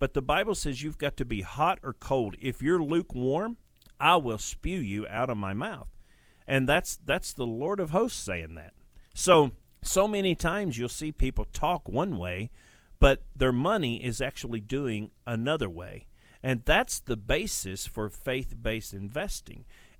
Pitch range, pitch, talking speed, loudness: 105-145 Hz, 120 Hz, 170 wpm, -29 LUFS